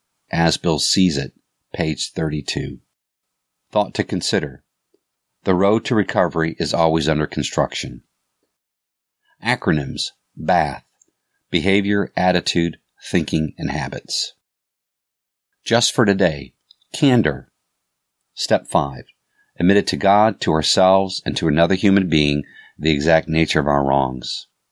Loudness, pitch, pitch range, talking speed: -19 LUFS, 80 Hz, 75-95 Hz, 115 wpm